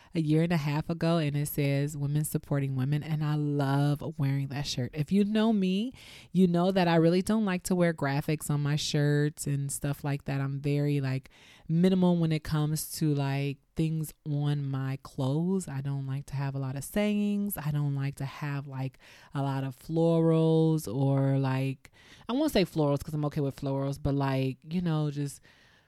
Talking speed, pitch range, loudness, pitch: 200 wpm, 140-165 Hz, -29 LUFS, 145 Hz